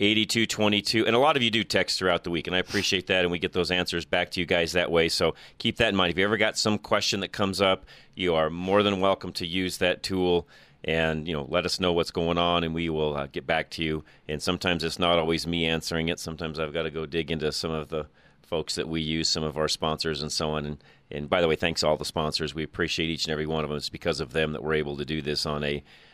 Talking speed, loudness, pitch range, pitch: 285 wpm, -26 LUFS, 80-90 Hz, 85 Hz